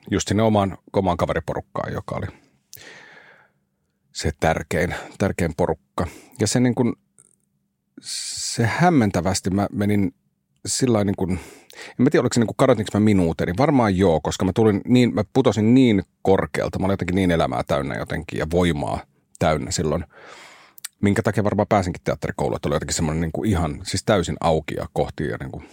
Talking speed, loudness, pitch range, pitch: 165 wpm, -21 LUFS, 90-110 Hz, 100 Hz